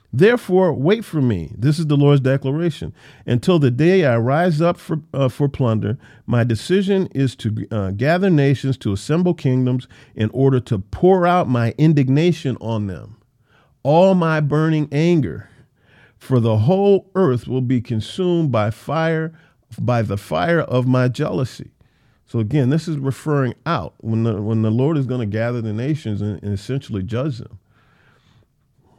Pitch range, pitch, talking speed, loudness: 115-160 Hz, 130 Hz, 165 wpm, -18 LUFS